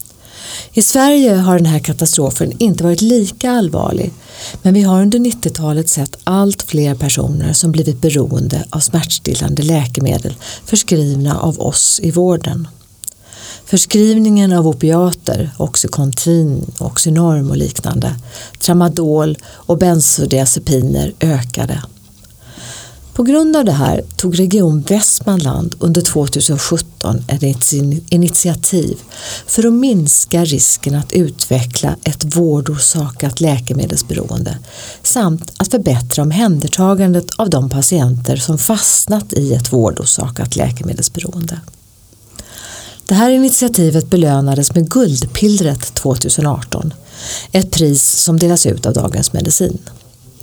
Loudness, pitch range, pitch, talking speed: -13 LUFS, 130-175 Hz, 155 Hz, 105 wpm